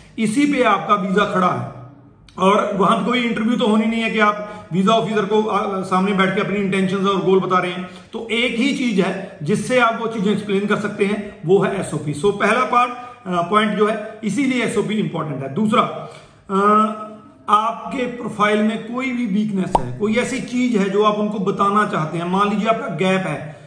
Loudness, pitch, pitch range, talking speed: -18 LUFS, 210 Hz, 190-225 Hz, 200 wpm